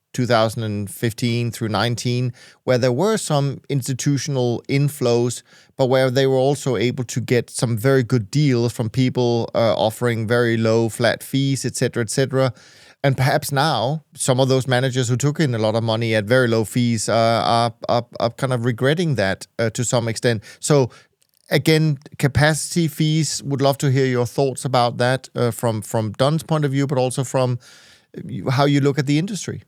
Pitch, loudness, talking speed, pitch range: 130 Hz, -20 LUFS, 185 wpm, 120-140 Hz